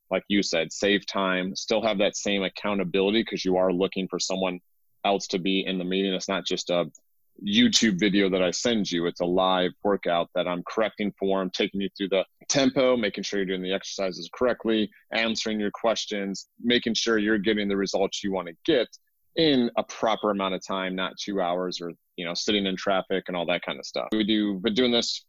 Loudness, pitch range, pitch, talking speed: -26 LUFS, 95-110 Hz, 95 Hz, 220 wpm